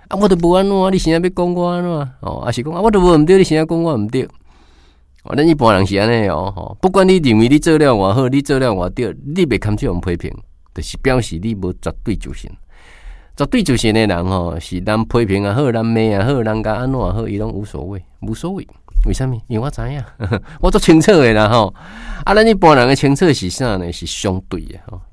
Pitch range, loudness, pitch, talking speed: 95-160 Hz, -15 LUFS, 120 Hz, 335 characters per minute